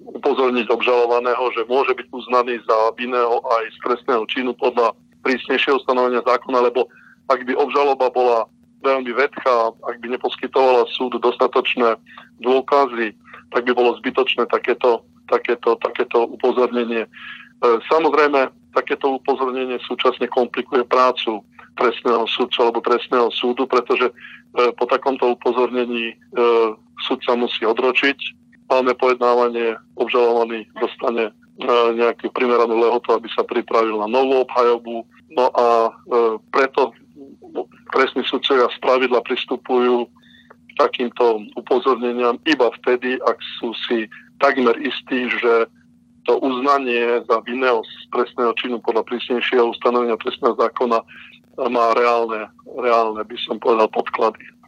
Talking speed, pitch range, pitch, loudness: 115 wpm, 115-125 Hz, 120 Hz, -19 LUFS